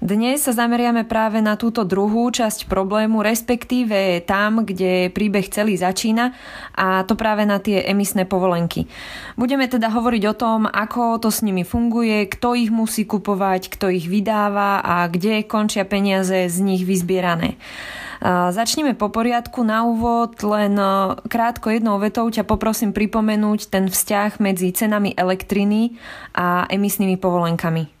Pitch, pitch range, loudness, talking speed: 210 Hz, 190-230 Hz, -19 LUFS, 140 wpm